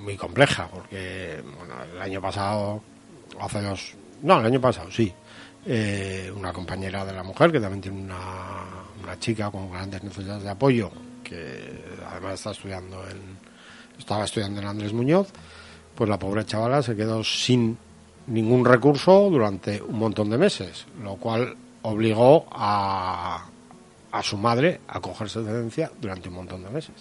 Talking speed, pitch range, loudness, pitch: 160 wpm, 95-115 Hz, -24 LUFS, 100 Hz